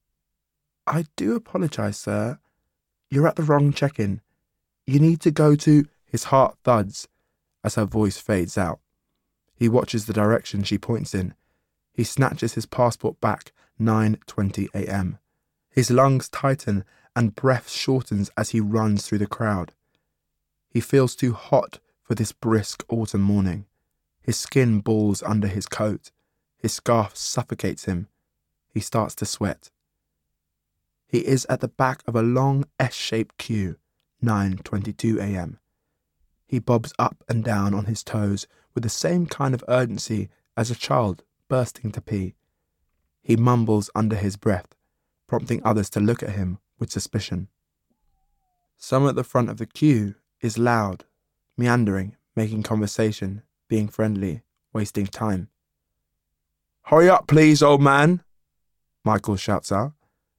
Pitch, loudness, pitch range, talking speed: 110 Hz, -23 LUFS, 100-125 Hz, 140 wpm